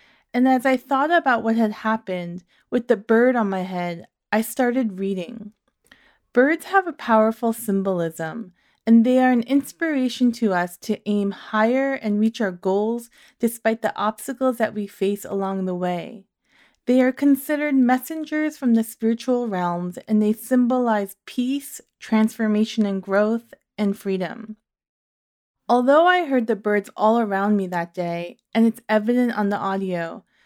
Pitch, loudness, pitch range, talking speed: 220 Hz, -21 LUFS, 195-250 Hz, 155 wpm